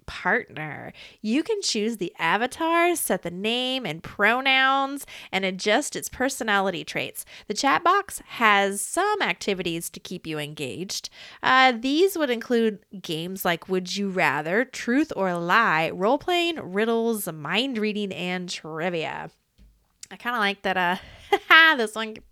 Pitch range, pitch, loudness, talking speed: 185-260 Hz, 210 Hz, -23 LUFS, 140 wpm